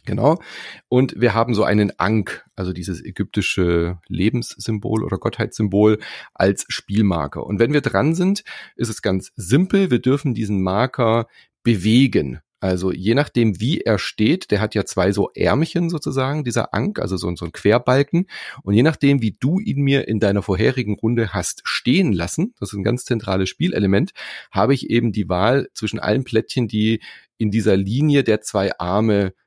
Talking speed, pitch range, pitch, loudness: 175 wpm, 100-125 Hz, 110 Hz, -19 LUFS